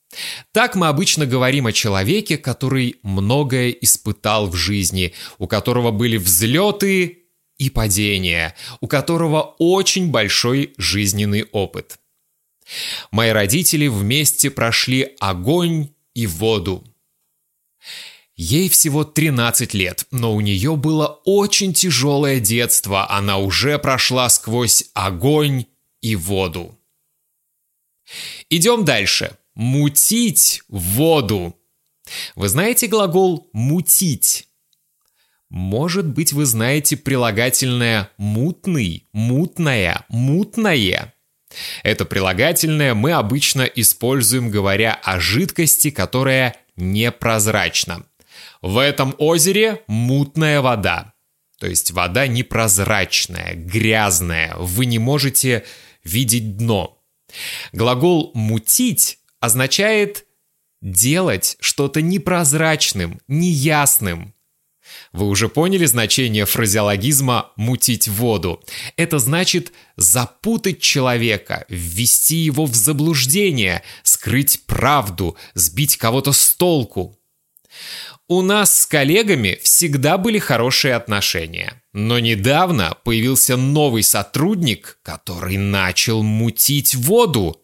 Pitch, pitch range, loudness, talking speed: 125 Hz, 105-150 Hz, -16 LUFS, 90 wpm